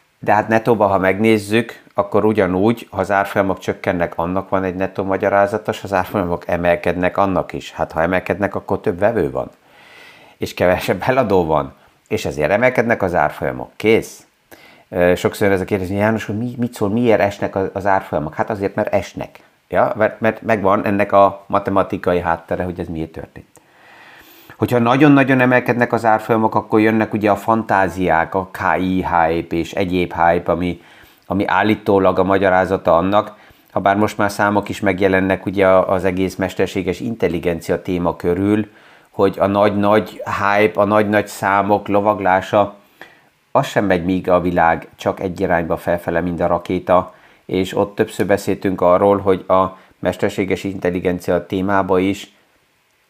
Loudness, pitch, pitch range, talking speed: -17 LUFS, 100 Hz, 90-105 Hz, 155 wpm